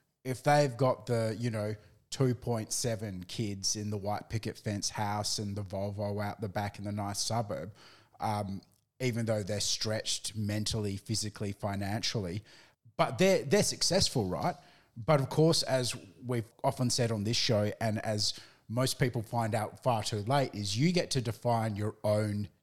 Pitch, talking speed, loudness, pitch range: 110 Hz, 165 wpm, -32 LUFS, 105-125 Hz